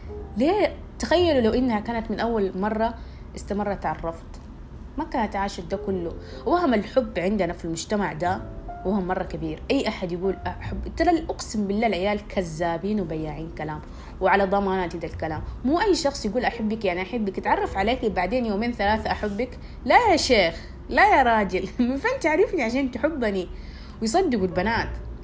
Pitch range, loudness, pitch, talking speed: 185-235 Hz, -24 LUFS, 205 Hz, 155 wpm